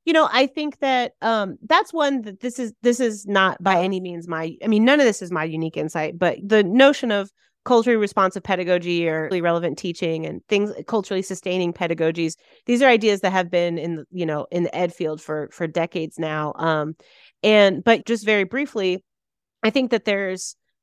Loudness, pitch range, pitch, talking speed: -21 LUFS, 170-230 Hz, 190 Hz, 205 wpm